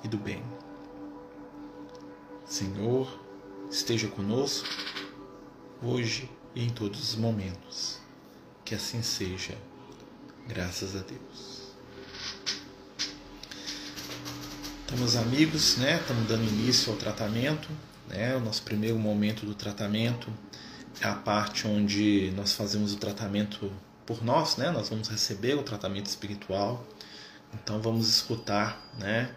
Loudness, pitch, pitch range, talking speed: -30 LUFS, 105 Hz, 100-115 Hz, 110 wpm